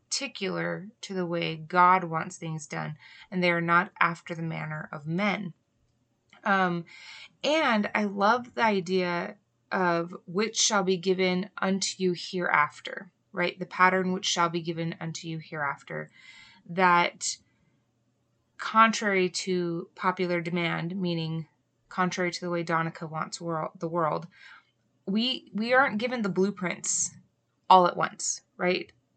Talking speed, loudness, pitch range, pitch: 135 wpm, -27 LUFS, 165-195 Hz, 180 Hz